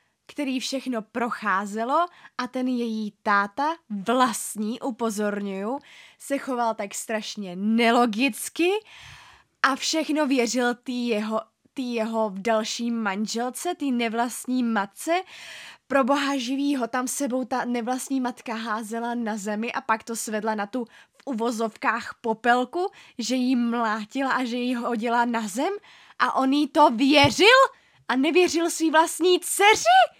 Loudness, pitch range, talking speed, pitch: -24 LUFS, 225-280 Hz, 135 wpm, 245 Hz